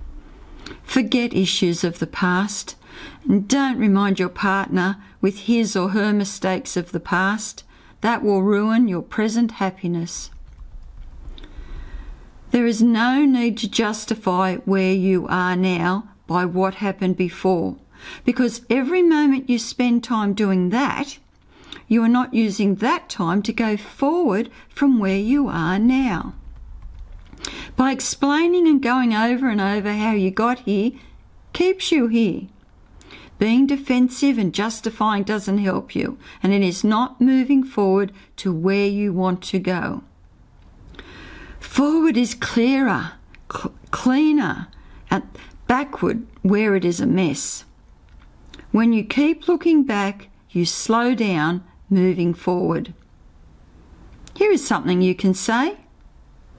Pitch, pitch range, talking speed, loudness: 210 Hz, 185-250 Hz, 125 wpm, -20 LUFS